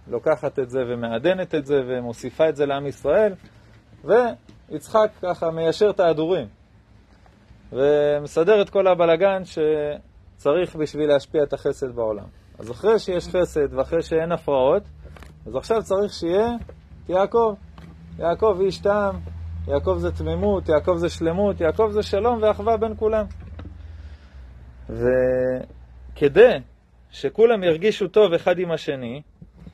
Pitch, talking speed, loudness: 155 Hz, 120 wpm, -21 LUFS